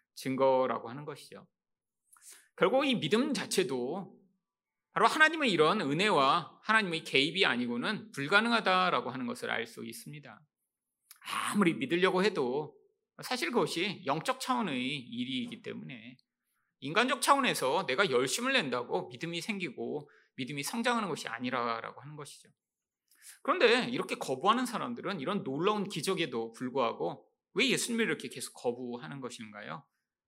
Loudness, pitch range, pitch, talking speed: -31 LUFS, 140-240 Hz, 195 Hz, 330 characters per minute